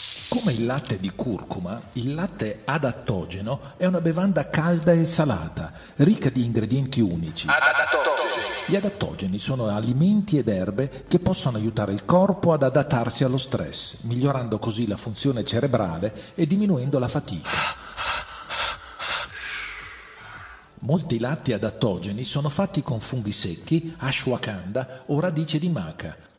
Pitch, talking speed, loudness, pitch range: 135 Hz, 125 wpm, -22 LUFS, 115-165 Hz